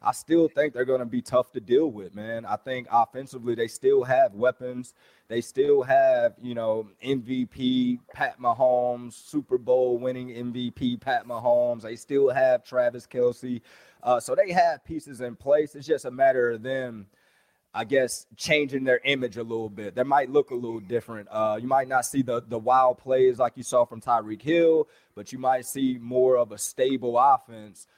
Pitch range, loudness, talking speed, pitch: 120-150 Hz, -25 LUFS, 190 wpm, 125 Hz